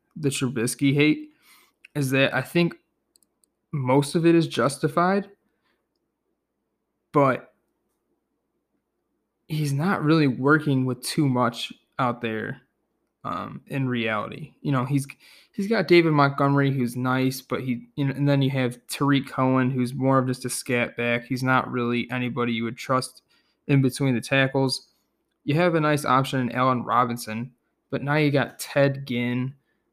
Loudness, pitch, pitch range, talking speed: -24 LUFS, 135 Hz, 125-145 Hz, 150 wpm